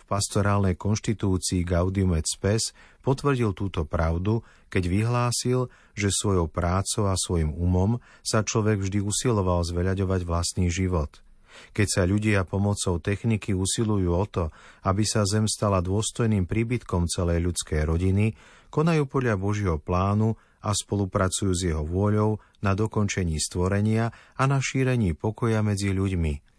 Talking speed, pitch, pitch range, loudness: 130 wpm, 100 Hz, 90-110 Hz, -25 LUFS